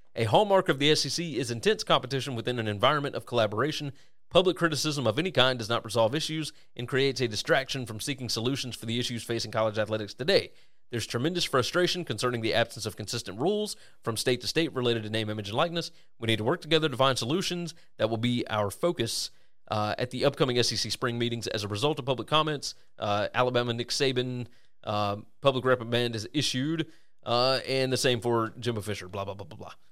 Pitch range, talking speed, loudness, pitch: 115-145 Hz, 205 wpm, -28 LUFS, 125 Hz